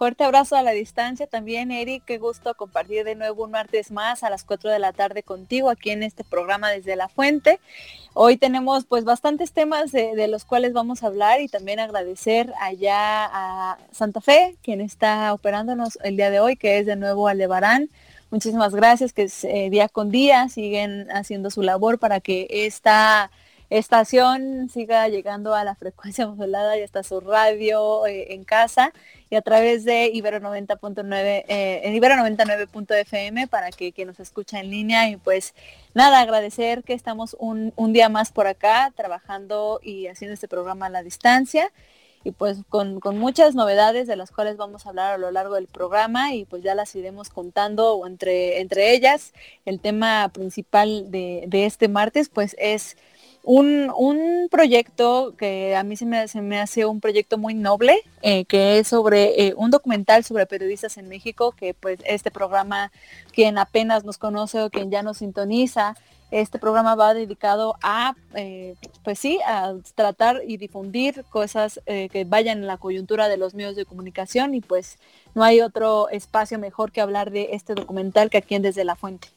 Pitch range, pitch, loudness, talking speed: 200-230 Hz, 215 Hz, -20 LUFS, 185 wpm